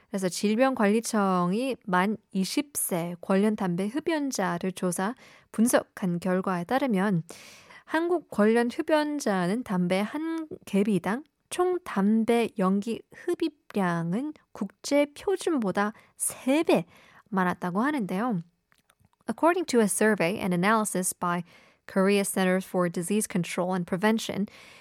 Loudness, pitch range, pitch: -27 LUFS, 185-265 Hz, 210 Hz